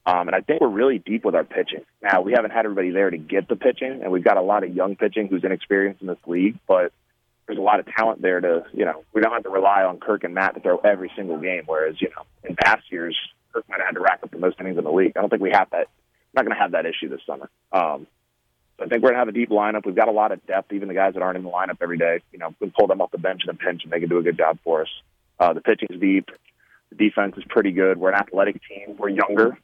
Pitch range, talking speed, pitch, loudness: 90-105 Hz, 315 wpm, 95 Hz, -21 LUFS